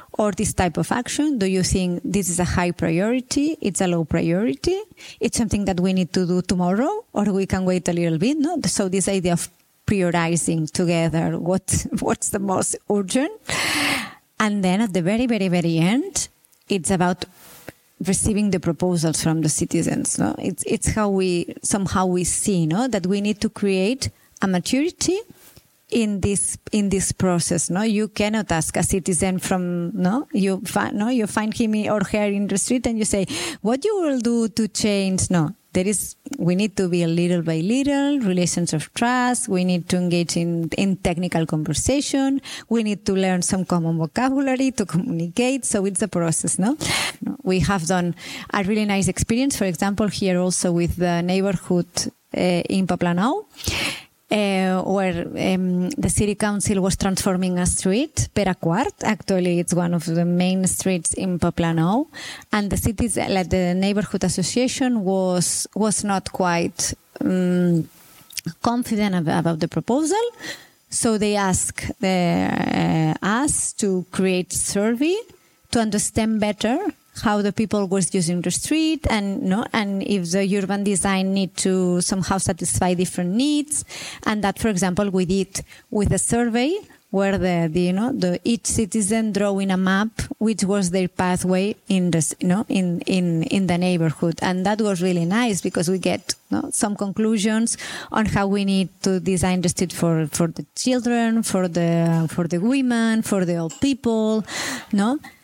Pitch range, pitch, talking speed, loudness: 180-220 Hz, 195 Hz, 170 wpm, -21 LUFS